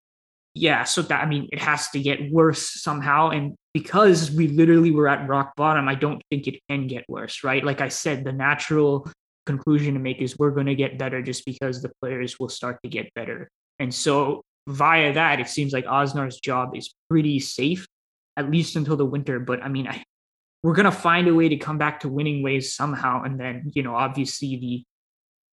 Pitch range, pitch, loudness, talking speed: 130-155 Hz, 140 Hz, -22 LUFS, 210 wpm